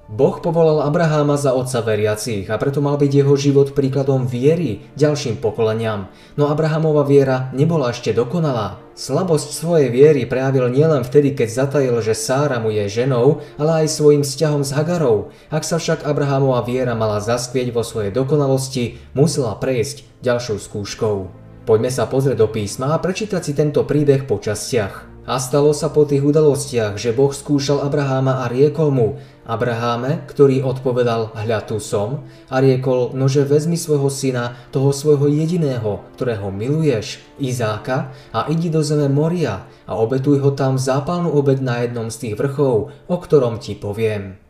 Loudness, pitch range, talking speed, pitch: -18 LUFS, 120-150 Hz, 160 wpm, 135 Hz